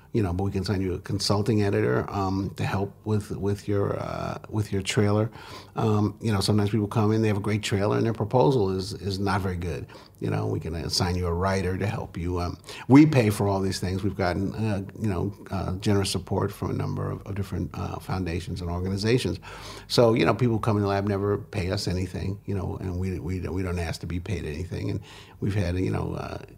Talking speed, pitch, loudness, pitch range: 240 wpm, 100 Hz, -26 LUFS, 95-105 Hz